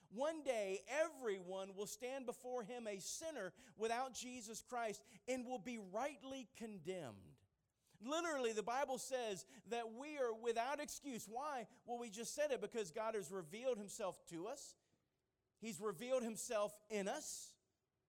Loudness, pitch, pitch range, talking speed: -46 LUFS, 230 Hz, 205-255 Hz, 145 wpm